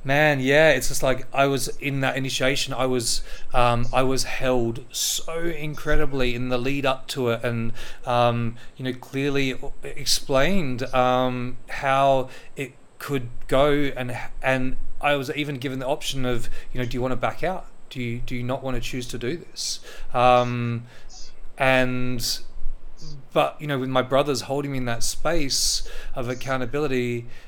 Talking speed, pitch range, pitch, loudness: 170 wpm, 125-140 Hz, 130 Hz, -24 LUFS